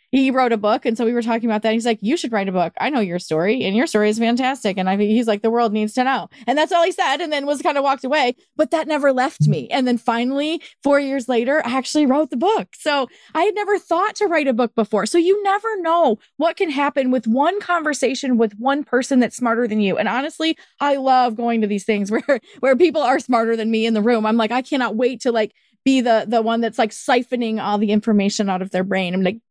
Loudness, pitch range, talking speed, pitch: -19 LUFS, 220-285 Hz, 270 wpm, 245 Hz